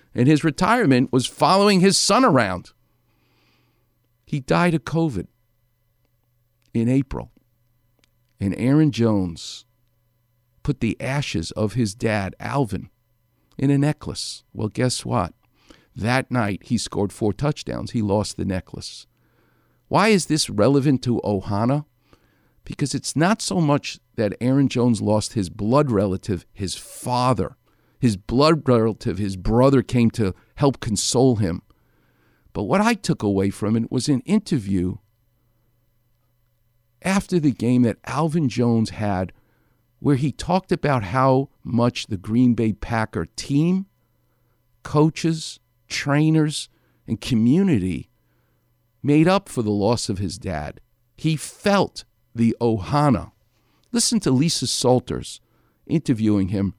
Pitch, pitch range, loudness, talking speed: 120 Hz, 110-140 Hz, -21 LUFS, 125 wpm